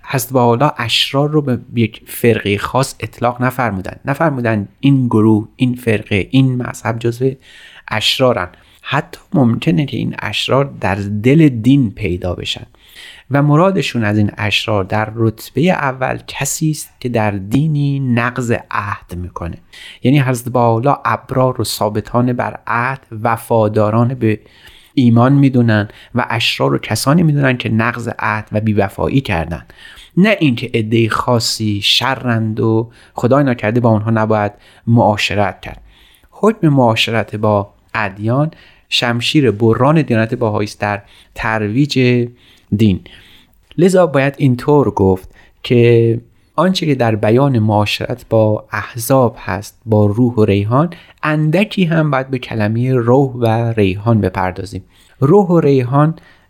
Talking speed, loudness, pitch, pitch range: 125 wpm, -15 LUFS, 115 Hz, 105-135 Hz